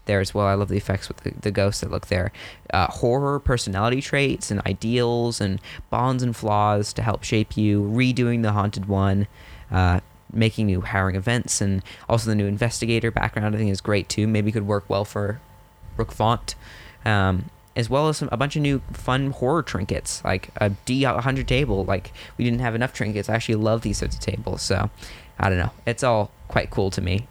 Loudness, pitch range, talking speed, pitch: -23 LUFS, 100-120 Hz, 205 wpm, 105 Hz